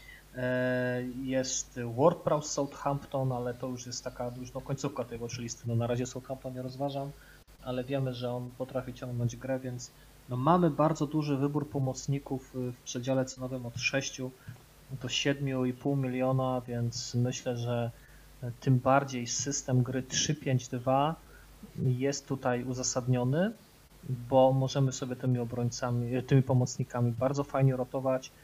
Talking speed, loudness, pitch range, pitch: 135 wpm, -31 LUFS, 125-140 Hz, 130 Hz